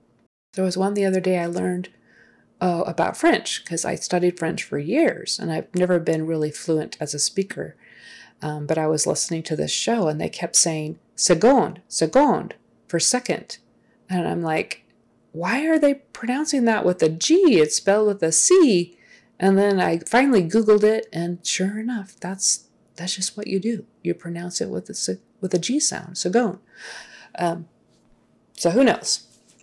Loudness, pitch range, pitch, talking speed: -21 LUFS, 165-215 Hz, 180 Hz, 175 wpm